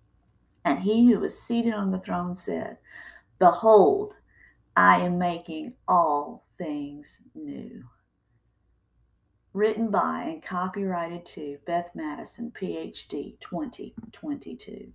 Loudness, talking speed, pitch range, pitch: -25 LUFS, 100 wpm, 175-290 Hz, 215 Hz